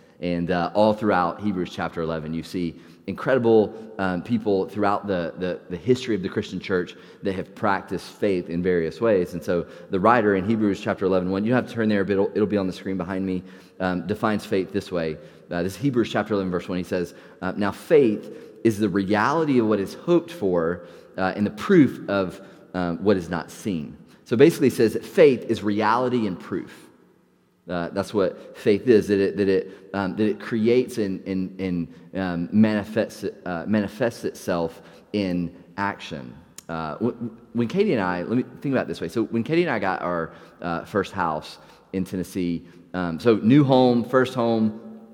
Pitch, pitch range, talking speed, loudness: 100 Hz, 90-110 Hz, 195 wpm, -23 LUFS